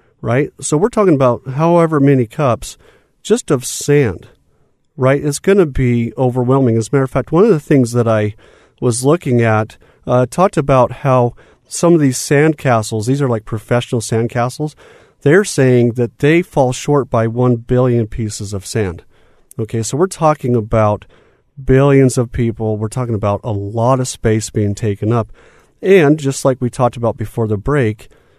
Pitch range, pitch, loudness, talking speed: 115-140 Hz, 125 Hz, -14 LUFS, 175 wpm